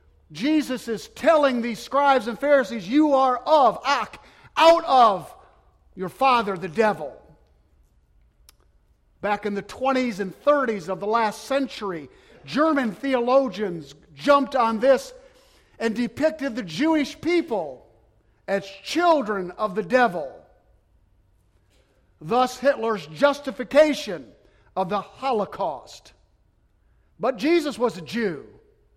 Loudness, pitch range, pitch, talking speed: -22 LUFS, 180-275 Hz, 230 Hz, 110 wpm